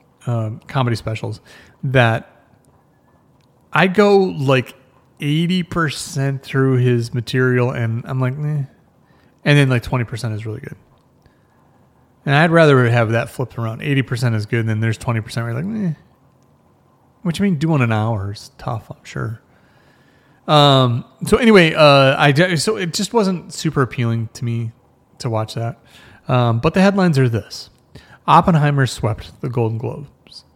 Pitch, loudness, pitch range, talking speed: 130 Hz, -17 LUFS, 115-155 Hz, 155 wpm